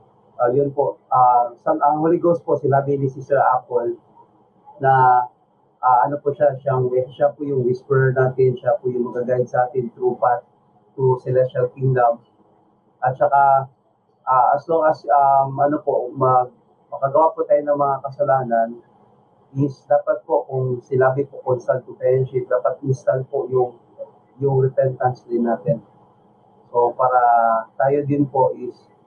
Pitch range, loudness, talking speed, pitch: 125-145 Hz, -19 LUFS, 155 wpm, 130 Hz